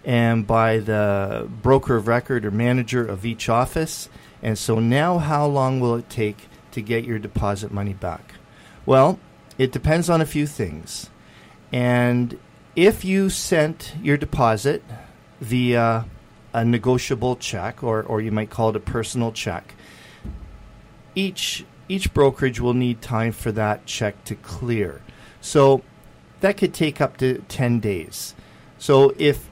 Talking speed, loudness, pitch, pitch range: 145 wpm, -21 LUFS, 120 Hz, 110-135 Hz